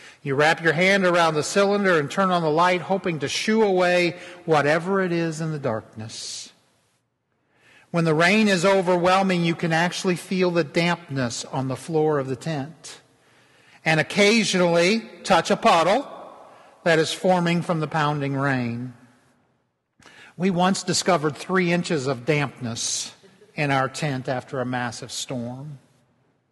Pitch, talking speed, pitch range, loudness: 160 Hz, 145 wpm, 135-180 Hz, -22 LUFS